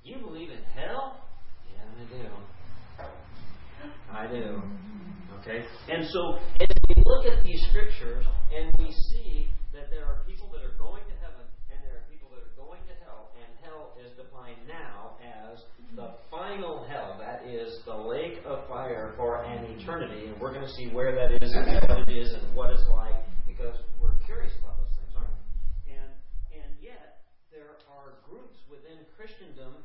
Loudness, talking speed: -33 LUFS, 180 wpm